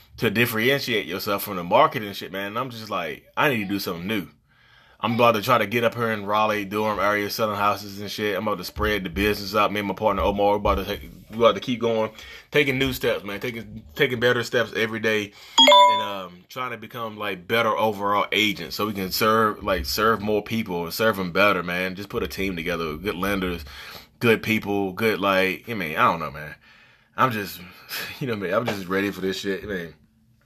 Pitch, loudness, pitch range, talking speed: 105 Hz, -23 LUFS, 95-110 Hz, 235 wpm